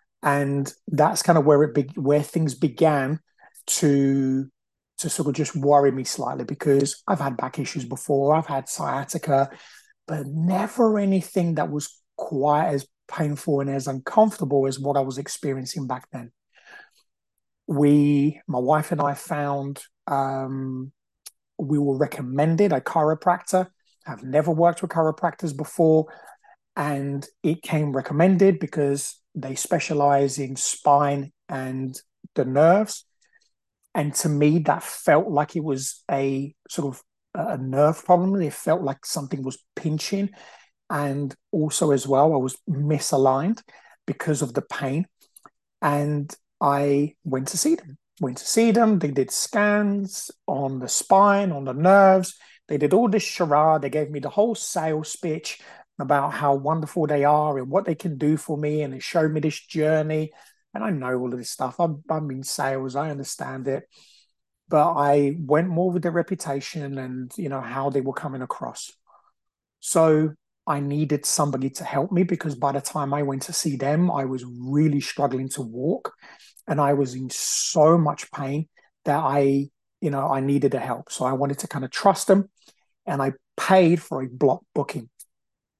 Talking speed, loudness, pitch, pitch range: 165 wpm, -23 LUFS, 145 Hz, 140-165 Hz